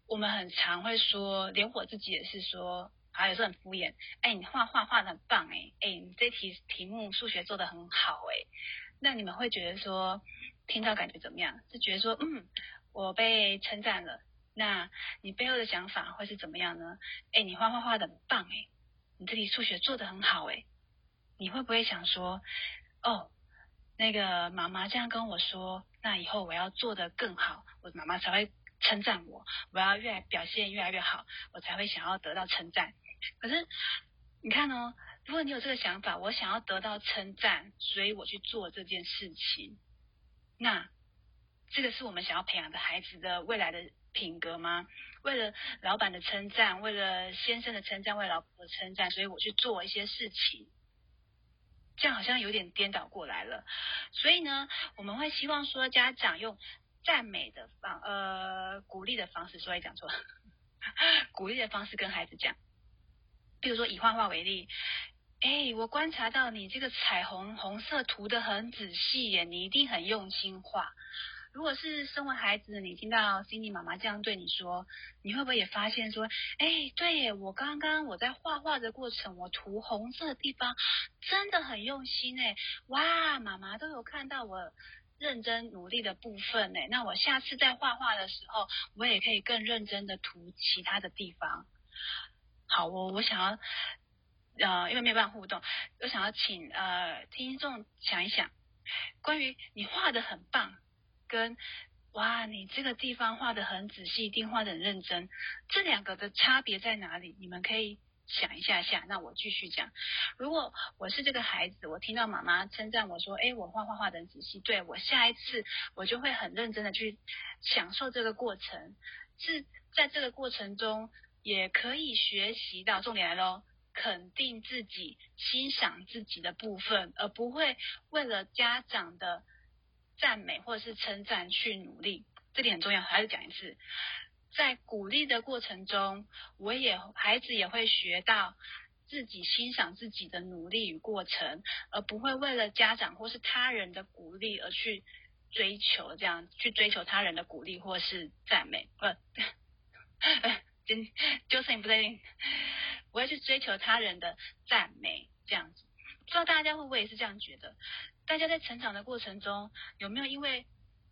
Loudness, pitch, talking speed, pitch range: -32 LUFS, 215 Hz, 260 characters per minute, 190-235 Hz